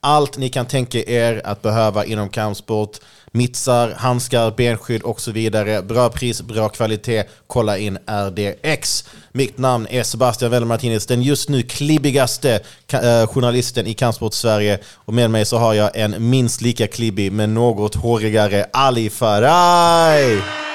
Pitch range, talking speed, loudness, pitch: 110-125 Hz, 145 wpm, -17 LUFS, 115 Hz